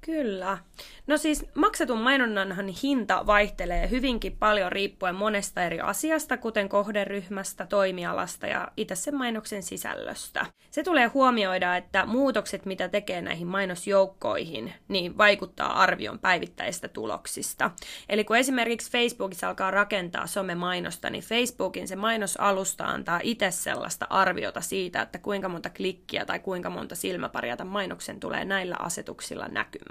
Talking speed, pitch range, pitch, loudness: 130 wpm, 190-235 Hz, 200 Hz, -27 LUFS